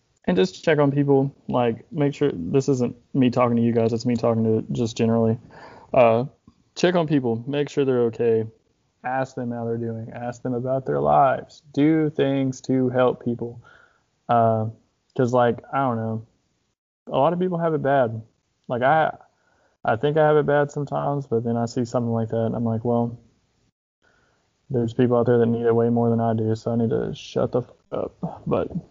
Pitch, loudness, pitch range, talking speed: 120 Hz, -22 LUFS, 115-135 Hz, 205 wpm